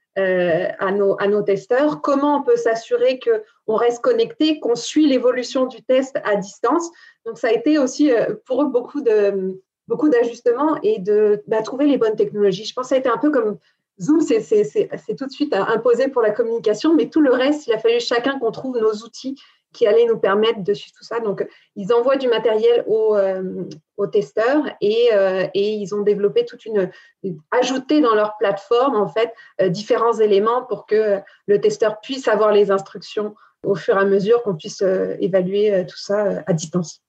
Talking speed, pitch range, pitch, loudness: 205 wpm, 205-270 Hz, 230 Hz, -19 LUFS